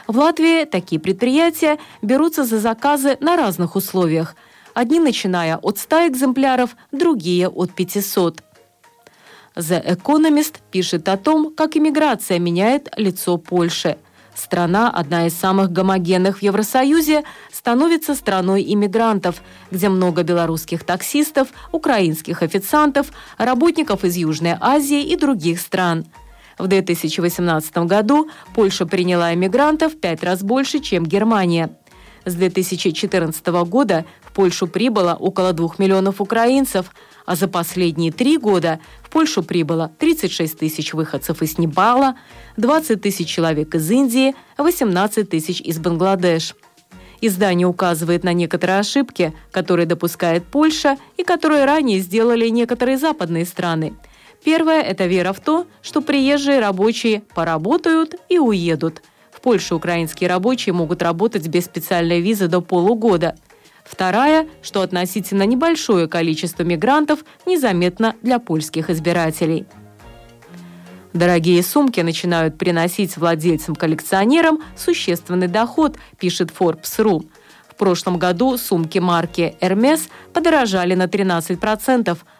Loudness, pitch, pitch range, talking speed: -17 LUFS, 190 Hz, 175-260 Hz, 115 wpm